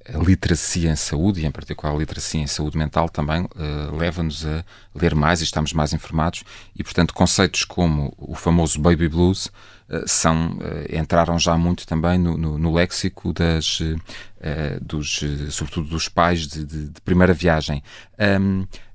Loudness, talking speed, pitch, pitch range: -21 LUFS, 170 wpm, 85 Hz, 75-90 Hz